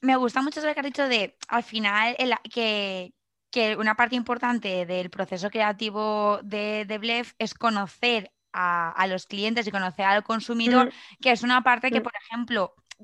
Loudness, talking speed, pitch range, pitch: -25 LUFS, 180 wpm, 205-245 Hz, 220 Hz